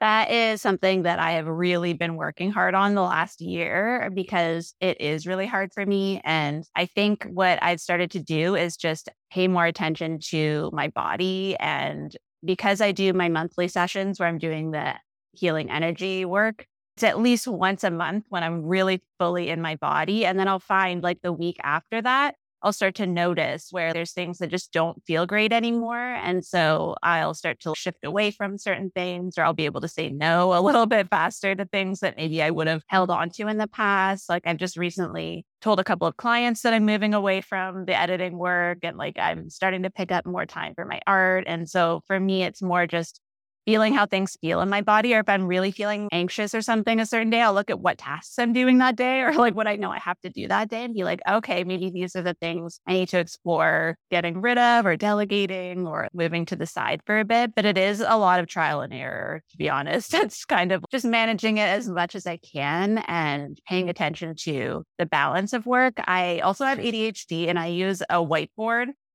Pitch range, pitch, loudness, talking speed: 170-210 Hz, 185 Hz, -24 LUFS, 225 wpm